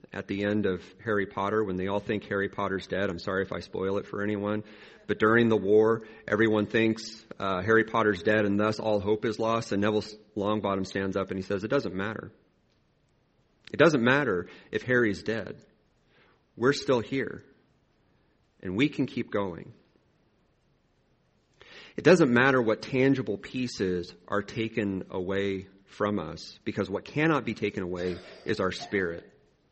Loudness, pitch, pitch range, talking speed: -28 LUFS, 105 Hz, 95-110 Hz, 165 wpm